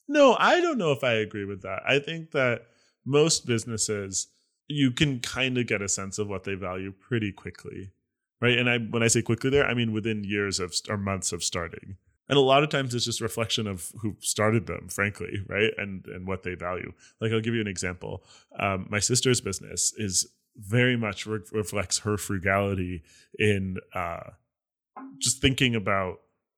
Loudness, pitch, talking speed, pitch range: -26 LUFS, 110 Hz, 190 wpm, 95-125 Hz